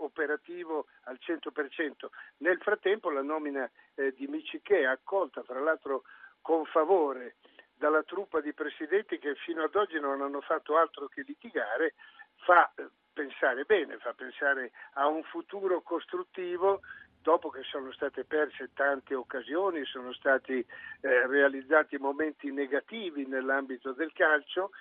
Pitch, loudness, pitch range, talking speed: 155 Hz, -31 LUFS, 140-210 Hz, 135 wpm